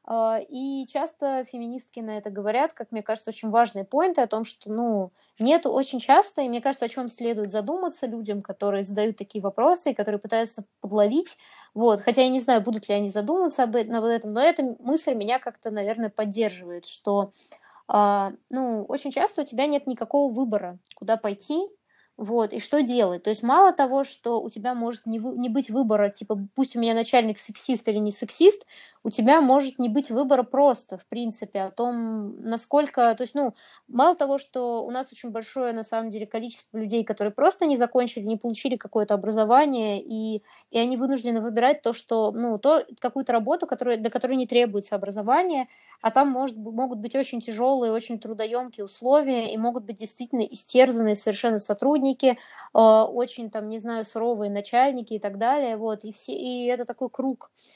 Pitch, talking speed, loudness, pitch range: 235 Hz, 180 wpm, -24 LUFS, 220-265 Hz